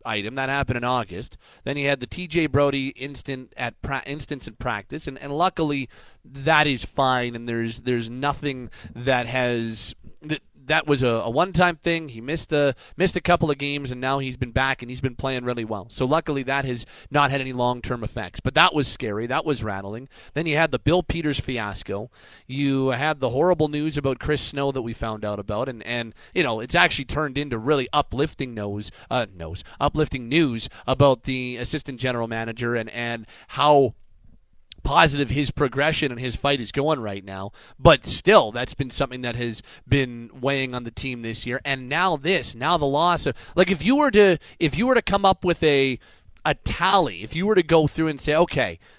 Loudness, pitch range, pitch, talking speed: -23 LUFS, 120-150 Hz, 135 Hz, 210 wpm